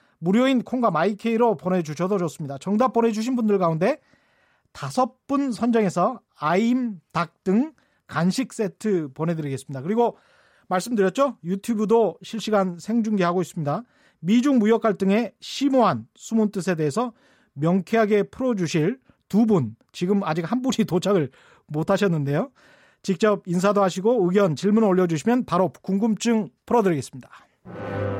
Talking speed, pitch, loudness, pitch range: 320 characters per minute, 205 Hz, -23 LUFS, 175-230 Hz